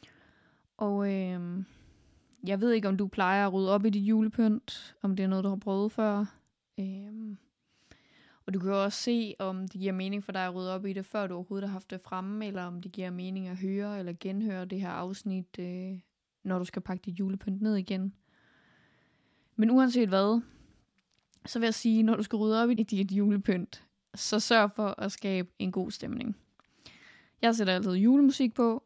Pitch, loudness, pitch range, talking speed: 195 Hz, -30 LUFS, 190-215 Hz, 200 wpm